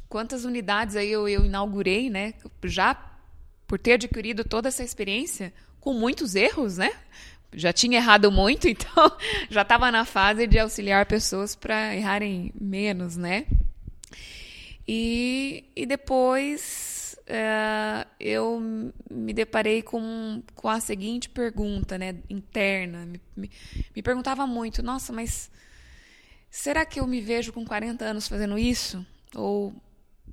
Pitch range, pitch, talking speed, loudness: 200-240 Hz, 220 Hz, 130 wpm, -25 LUFS